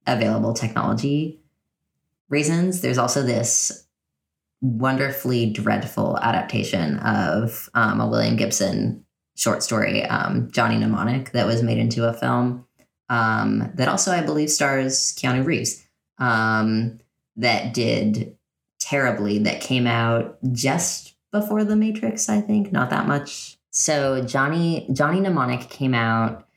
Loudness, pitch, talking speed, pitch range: -21 LUFS, 125 Hz, 125 wpm, 115-145 Hz